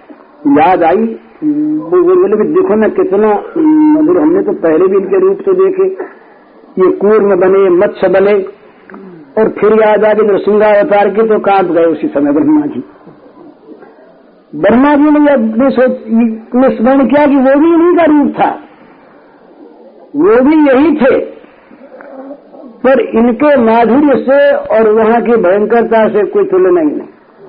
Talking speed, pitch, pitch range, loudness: 150 wpm, 270 Hz, 215-310 Hz, -9 LUFS